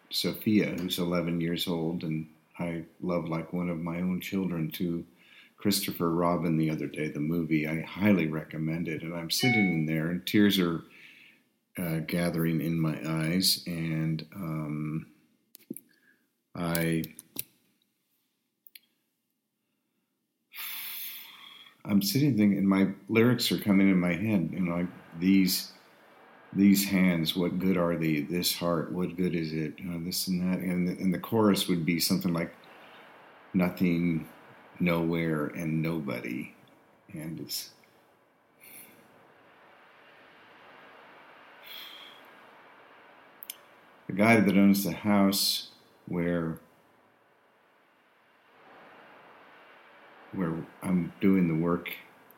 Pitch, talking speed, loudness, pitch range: 85 Hz, 115 wpm, -28 LUFS, 80-95 Hz